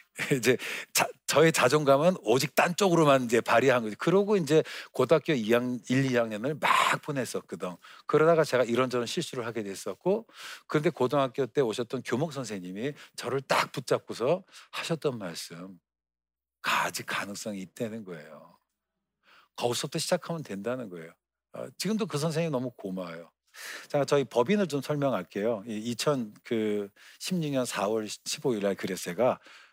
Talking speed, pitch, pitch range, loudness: 305 characters per minute, 125 Hz, 110-155 Hz, -28 LUFS